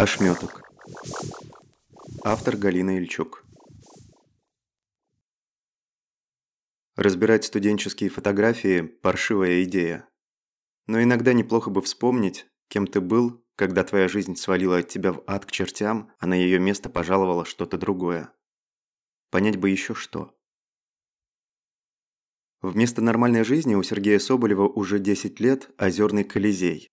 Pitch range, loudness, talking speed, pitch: 95-110 Hz, -23 LUFS, 110 wpm, 100 Hz